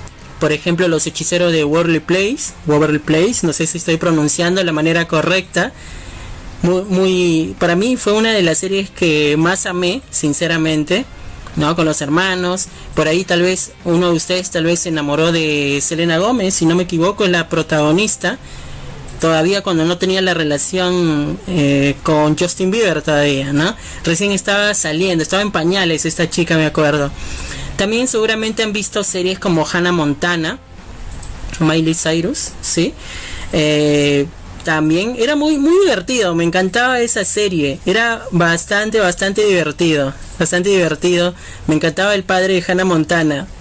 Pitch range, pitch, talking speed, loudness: 155-185 Hz, 170 Hz, 155 wpm, -14 LUFS